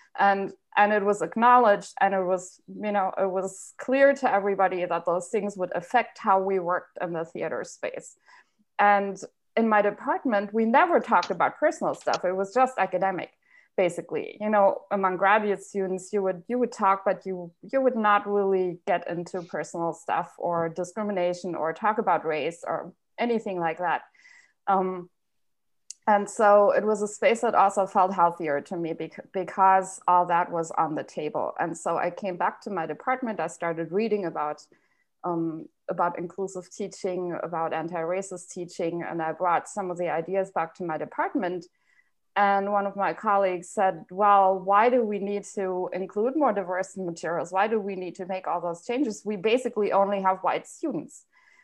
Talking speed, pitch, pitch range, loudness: 180 wpm, 195 Hz, 180-210 Hz, -26 LUFS